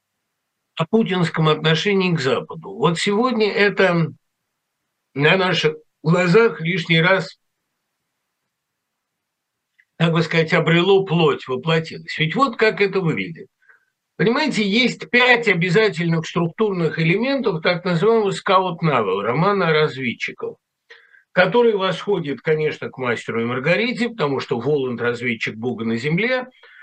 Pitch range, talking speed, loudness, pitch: 160-210 Hz, 115 wpm, -19 LUFS, 180 Hz